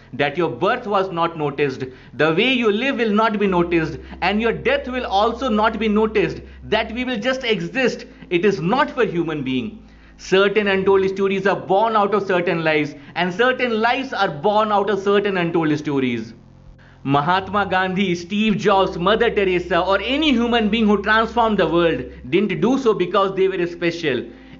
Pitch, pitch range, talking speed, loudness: 195 Hz, 175-220 Hz, 180 wpm, -19 LUFS